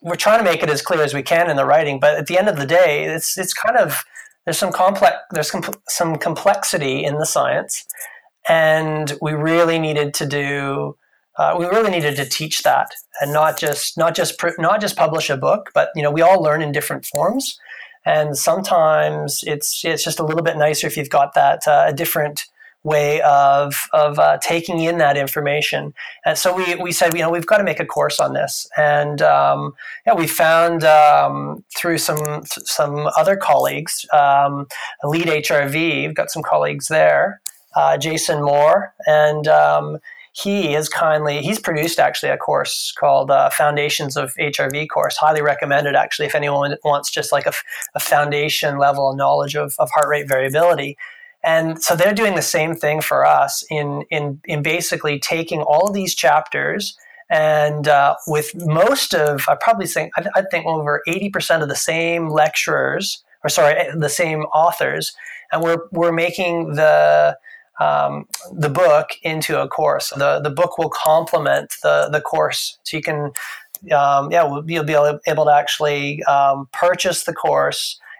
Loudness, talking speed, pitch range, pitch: -17 LUFS, 180 wpm, 145-170 Hz, 155 Hz